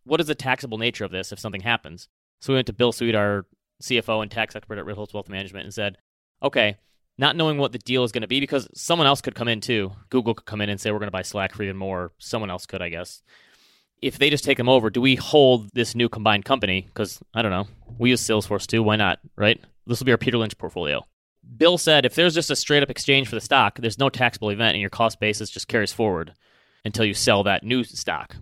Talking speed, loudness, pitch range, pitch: 260 wpm, -22 LUFS, 105-130 Hz, 115 Hz